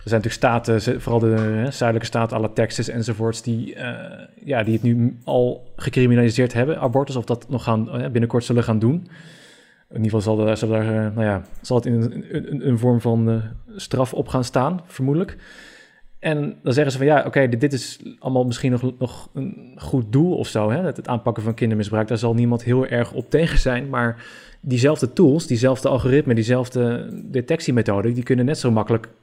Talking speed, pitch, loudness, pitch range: 200 wpm, 120 Hz, -21 LUFS, 115-130 Hz